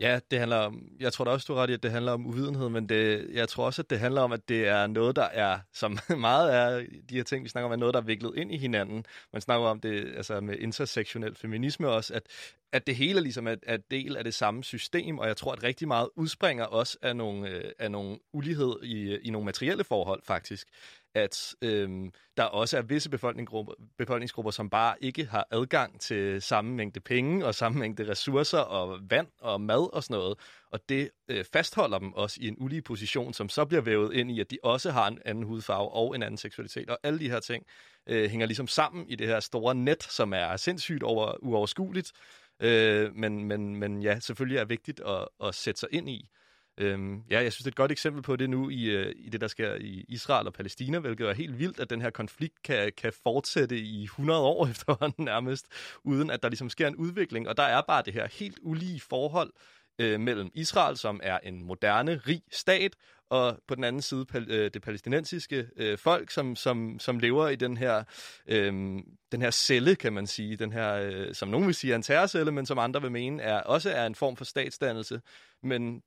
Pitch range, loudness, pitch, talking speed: 110-135 Hz, -30 LUFS, 120 Hz, 225 wpm